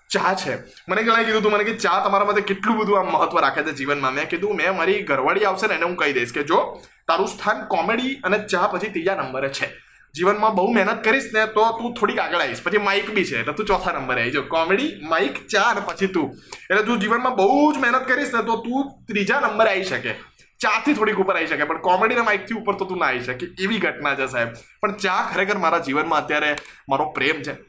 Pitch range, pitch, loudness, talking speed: 170-225 Hz, 200 Hz, -21 LUFS, 240 wpm